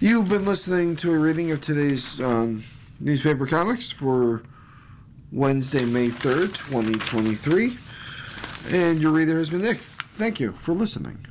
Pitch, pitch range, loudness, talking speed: 145 Hz, 125-170 Hz, -23 LUFS, 140 wpm